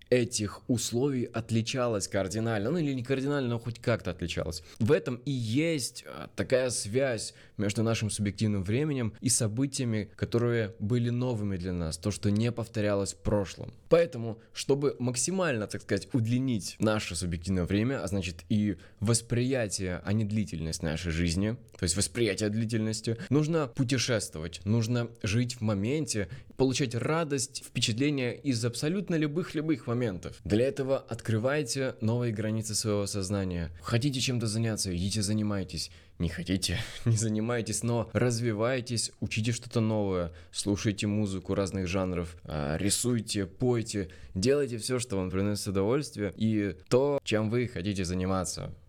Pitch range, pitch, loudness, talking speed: 100-125 Hz, 110 Hz, -30 LUFS, 135 wpm